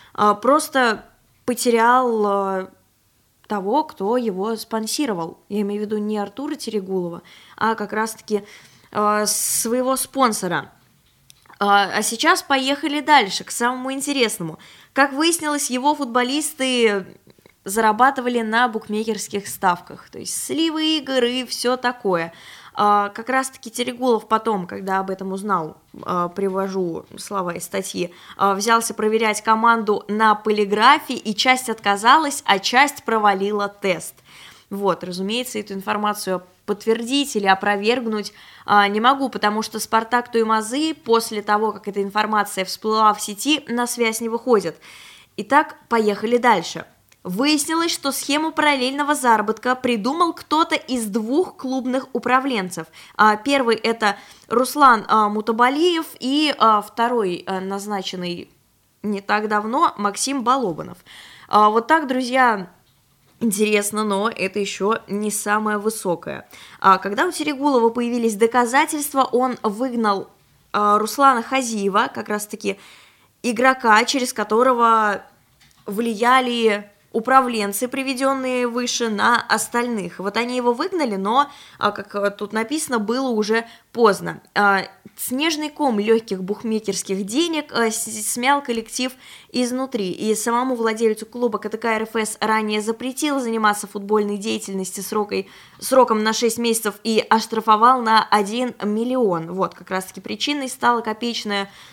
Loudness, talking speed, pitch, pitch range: -20 LUFS, 115 wpm, 220 Hz, 205-255 Hz